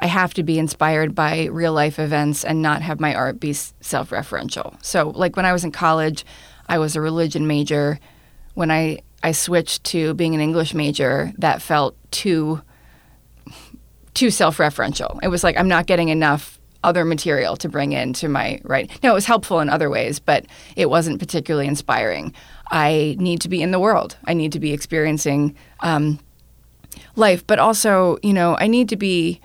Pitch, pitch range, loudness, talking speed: 160 Hz, 150-175 Hz, -19 LUFS, 185 wpm